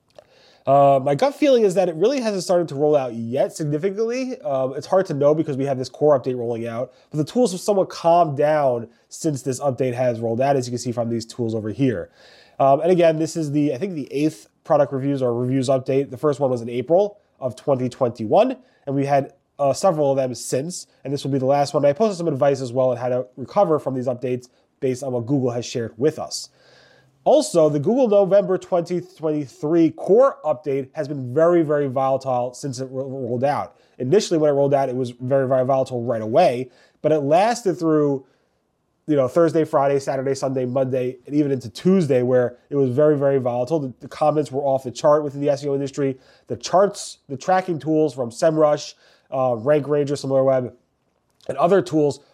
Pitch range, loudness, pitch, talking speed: 130-155 Hz, -20 LUFS, 140 Hz, 210 wpm